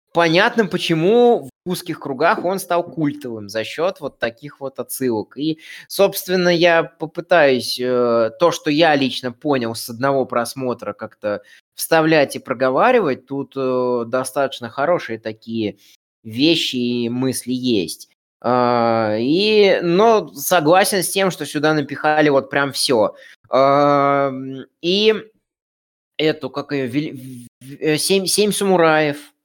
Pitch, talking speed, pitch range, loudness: 140 Hz, 115 wpm, 125-170 Hz, -18 LUFS